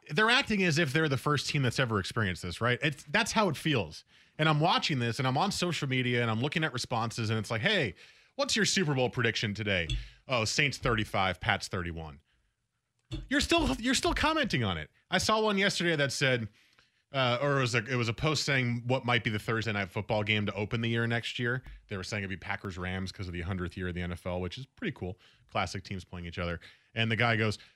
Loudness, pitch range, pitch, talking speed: -30 LUFS, 100-150 Hz, 120 Hz, 240 wpm